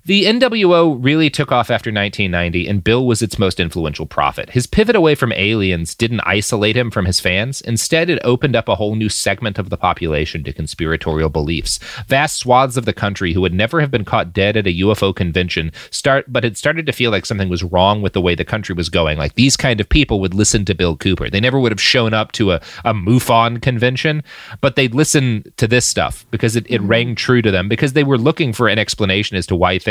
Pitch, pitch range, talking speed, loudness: 110 Hz, 95-125 Hz, 235 wpm, -15 LUFS